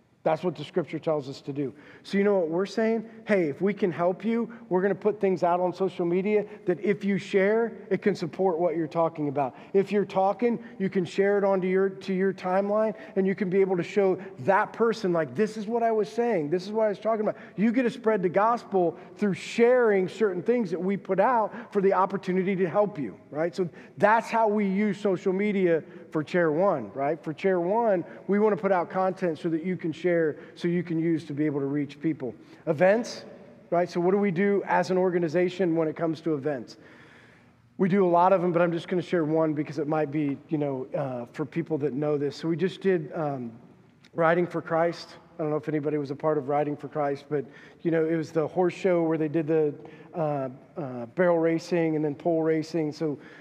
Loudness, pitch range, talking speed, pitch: -26 LUFS, 155-195 Hz, 240 wpm, 180 Hz